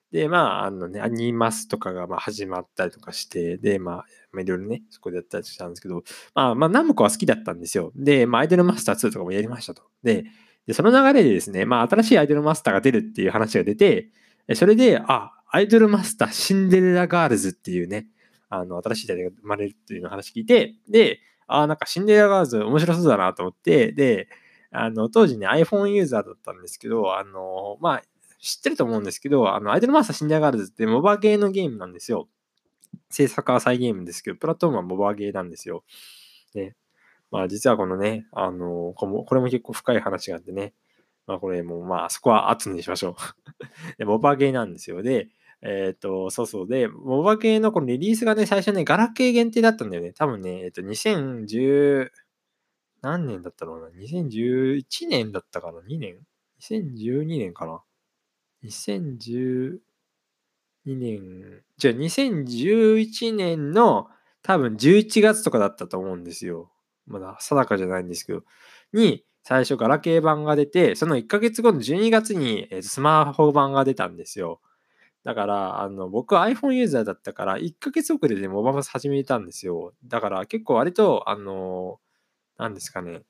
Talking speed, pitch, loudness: 380 characters per minute, 135 Hz, -22 LUFS